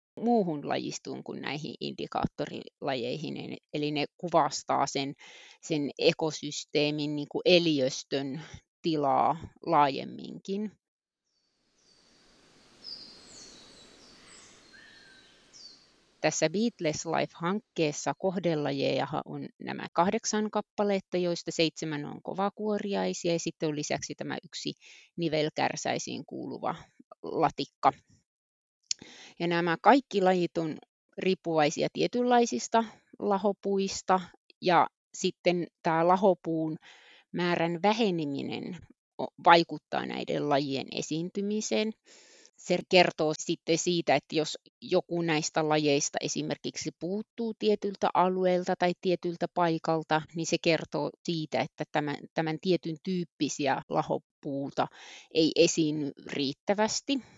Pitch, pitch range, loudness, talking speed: 170 Hz, 155-195 Hz, -29 LUFS, 85 wpm